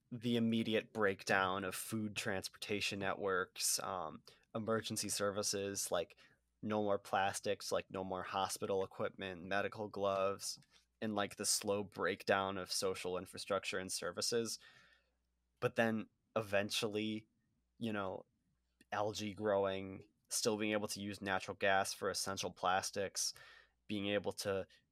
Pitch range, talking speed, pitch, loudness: 95-110 Hz, 125 wpm, 100 Hz, -39 LUFS